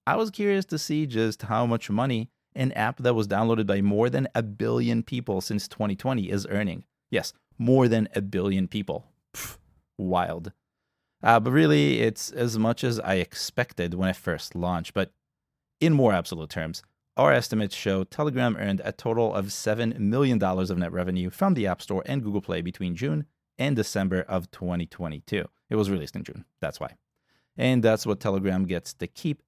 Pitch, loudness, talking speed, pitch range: 105 Hz, -26 LUFS, 185 wpm, 95-120 Hz